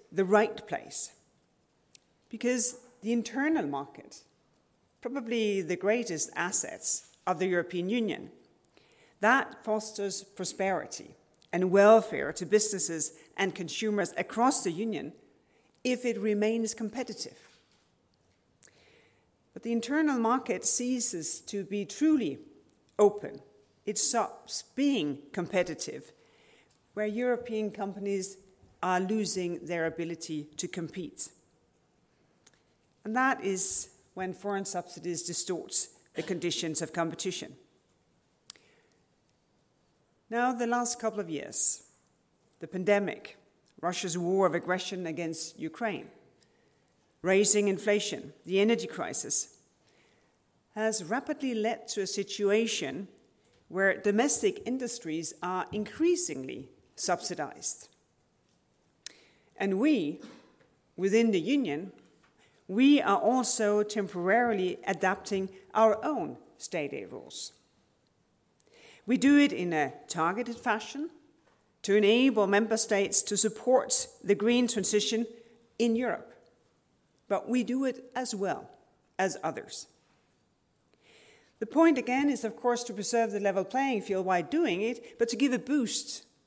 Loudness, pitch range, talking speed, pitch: -29 LUFS, 185-240 Hz, 110 wpm, 210 Hz